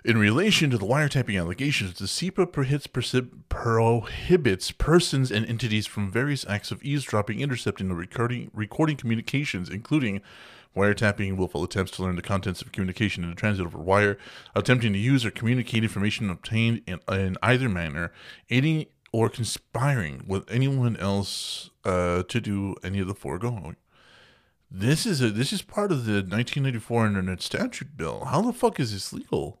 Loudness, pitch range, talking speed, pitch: -26 LUFS, 95-130 Hz, 160 wpm, 110 Hz